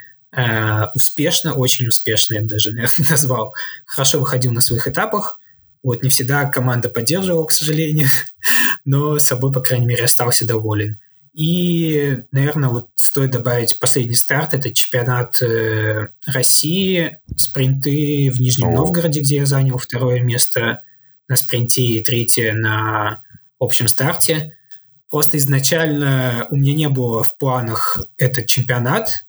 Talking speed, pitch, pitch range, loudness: 125 wpm, 130 Hz, 120-145 Hz, -14 LUFS